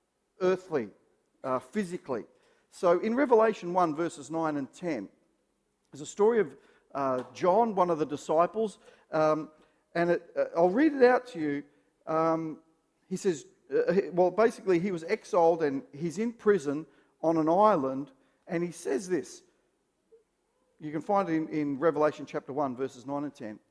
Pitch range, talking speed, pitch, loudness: 150-215 Hz, 160 wpm, 170 Hz, -29 LUFS